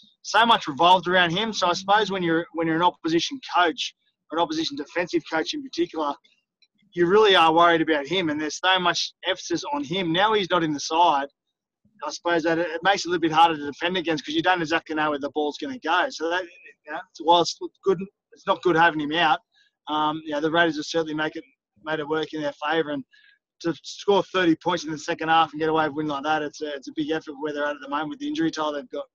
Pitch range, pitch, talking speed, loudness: 155-190 Hz, 170 Hz, 260 wpm, -23 LUFS